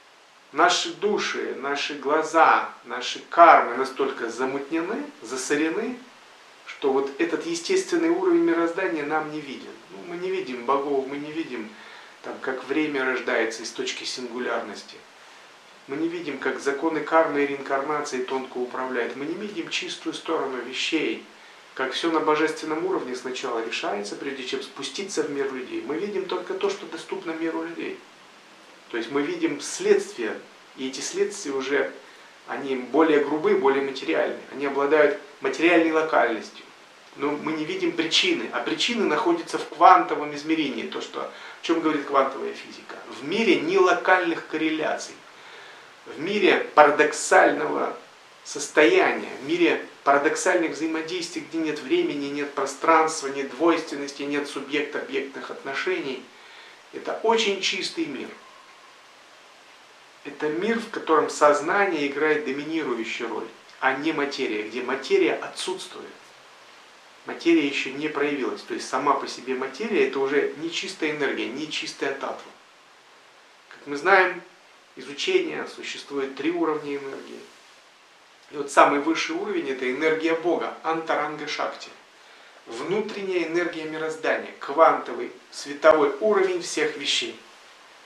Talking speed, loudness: 130 wpm, -24 LUFS